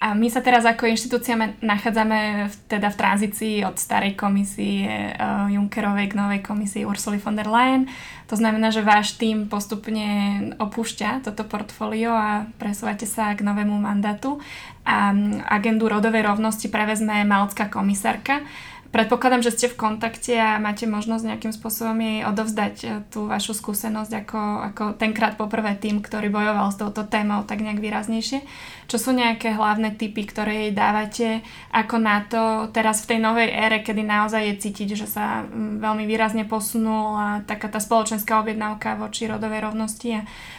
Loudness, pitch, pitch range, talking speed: -22 LUFS, 215 Hz, 210-225 Hz, 155 wpm